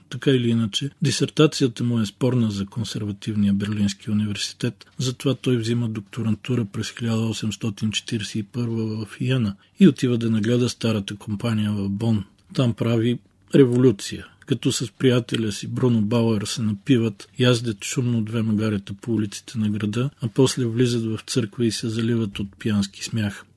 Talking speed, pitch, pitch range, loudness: 145 wpm, 115 Hz, 105-125 Hz, -23 LUFS